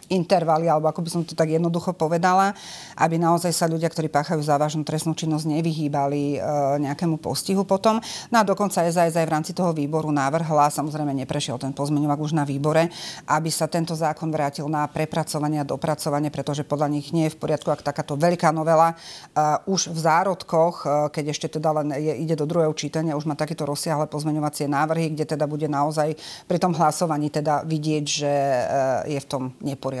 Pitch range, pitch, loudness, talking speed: 150-165 Hz, 155 Hz, -23 LUFS, 180 wpm